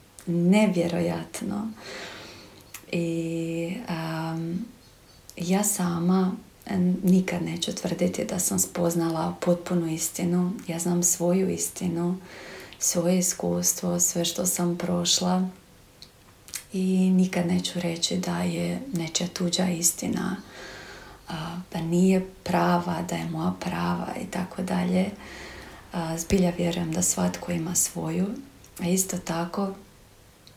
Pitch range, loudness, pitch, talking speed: 170-185 Hz, -26 LUFS, 175 Hz, 105 wpm